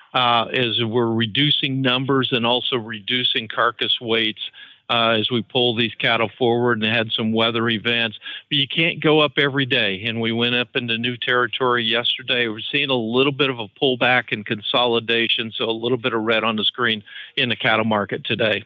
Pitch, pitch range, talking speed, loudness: 120 Hz, 115-130 Hz, 195 wpm, -19 LUFS